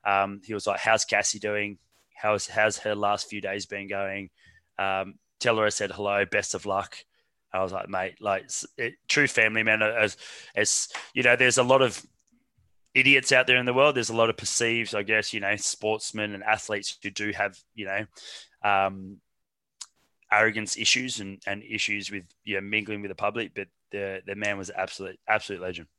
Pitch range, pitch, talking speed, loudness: 100-110 Hz, 105 Hz, 200 wpm, -25 LUFS